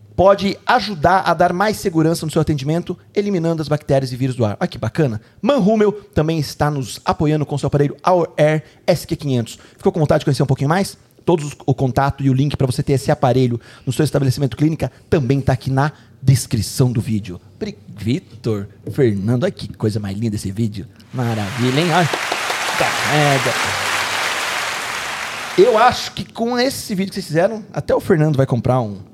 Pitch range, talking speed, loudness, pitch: 125-170 Hz, 190 wpm, -18 LUFS, 145 Hz